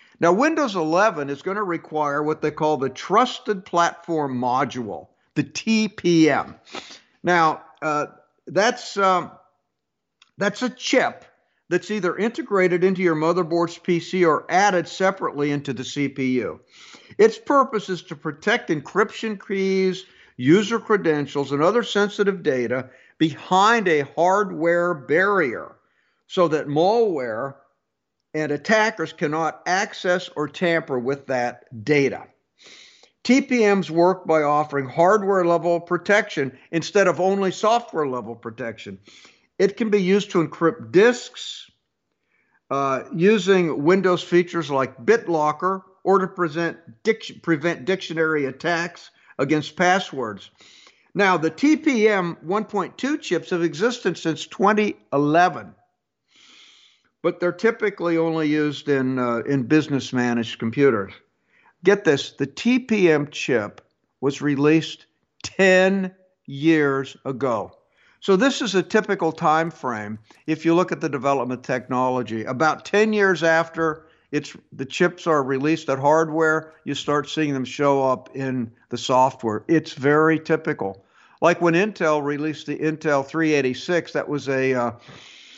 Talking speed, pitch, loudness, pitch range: 125 wpm, 165 Hz, -21 LUFS, 145-190 Hz